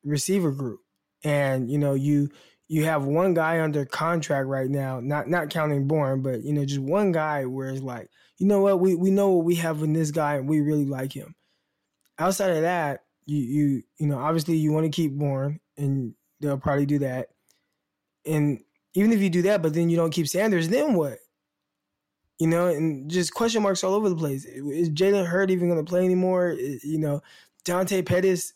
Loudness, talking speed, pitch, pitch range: -24 LUFS, 205 wpm, 155 Hz, 140-180 Hz